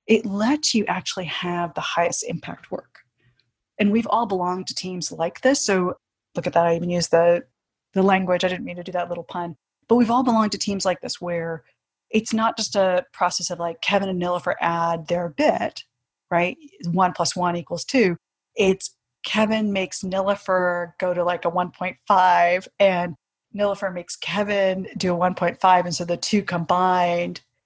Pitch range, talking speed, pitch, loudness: 175-200 Hz, 180 wpm, 180 Hz, -22 LUFS